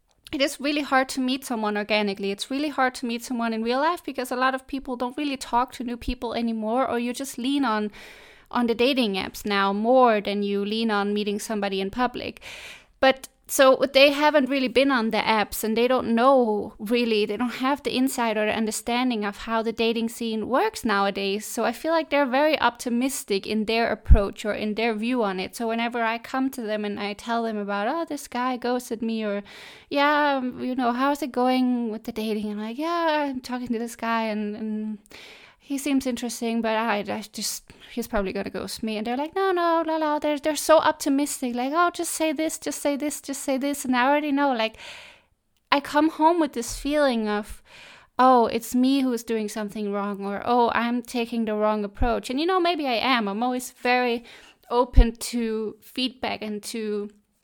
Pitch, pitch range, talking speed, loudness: 240 Hz, 220-275 Hz, 210 wpm, -24 LUFS